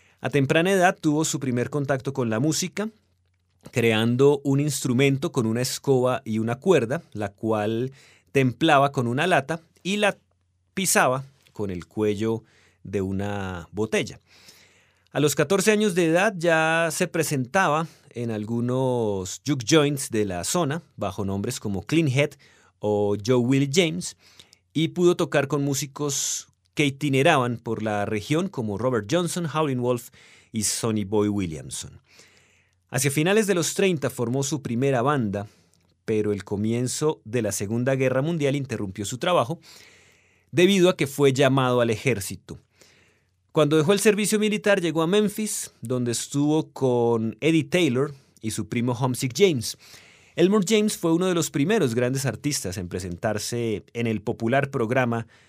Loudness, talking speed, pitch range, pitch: -24 LUFS, 150 wpm, 110-155 Hz, 130 Hz